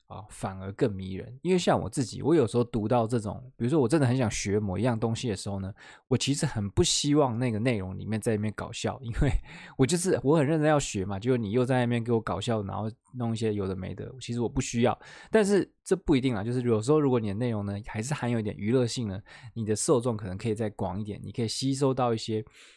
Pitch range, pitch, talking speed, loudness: 105-130 Hz, 120 Hz, 375 characters per minute, -28 LUFS